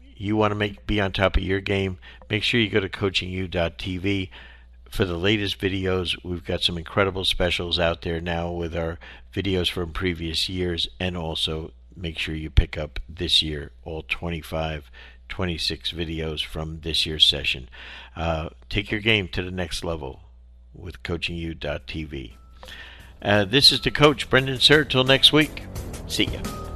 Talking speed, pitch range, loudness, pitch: 165 wpm, 80-100 Hz, -23 LUFS, 85 Hz